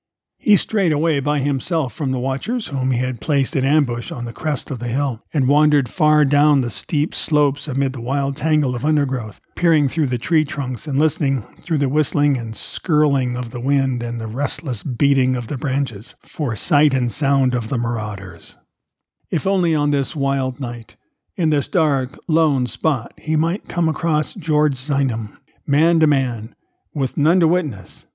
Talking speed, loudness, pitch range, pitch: 185 wpm, -19 LUFS, 130-155 Hz, 140 Hz